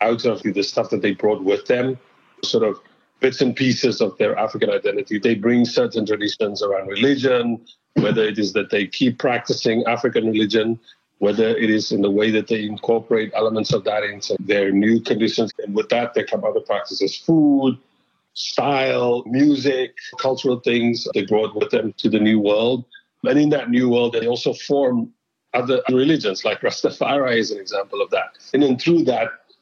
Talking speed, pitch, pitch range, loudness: 180 wpm, 120 Hz, 110-140 Hz, -20 LUFS